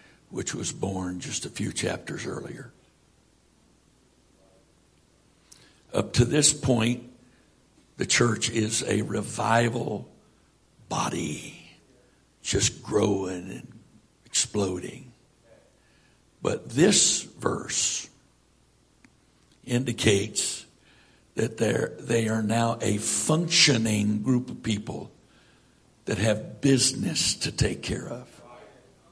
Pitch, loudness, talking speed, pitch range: 115 Hz, -25 LUFS, 85 wpm, 105-125 Hz